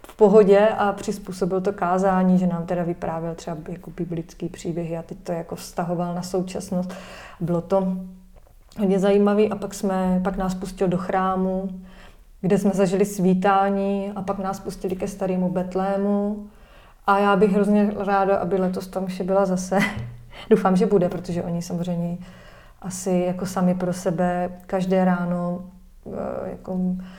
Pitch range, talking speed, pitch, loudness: 180-195 Hz, 150 wpm, 190 Hz, -23 LUFS